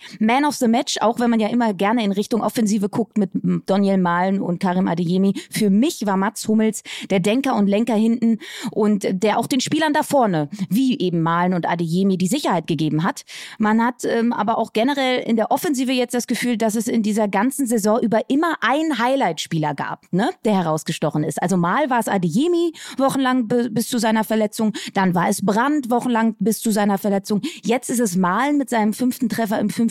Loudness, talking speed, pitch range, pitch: -20 LUFS, 205 wpm, 195-245 Hz, 220 Hz